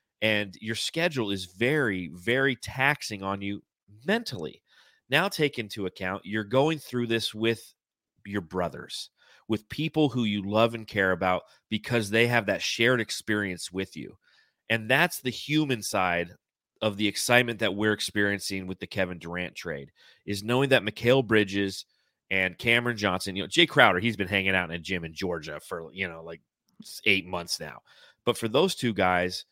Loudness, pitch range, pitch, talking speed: -27 LUFS, 95-120 Hz, 105 Hz, 175 wpm